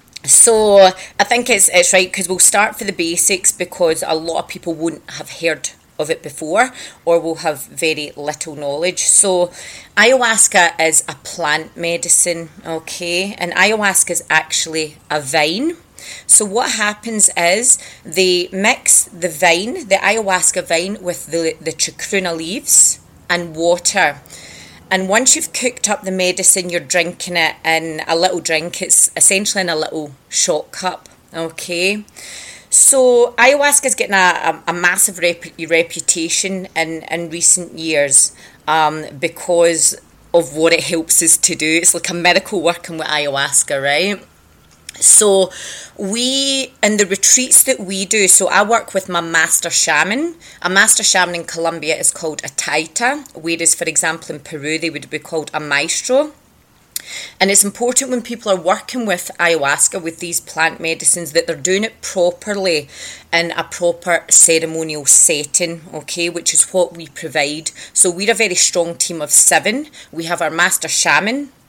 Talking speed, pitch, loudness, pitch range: 160 wpm, 175 Hz, -13 LUFS, 160-195 Hz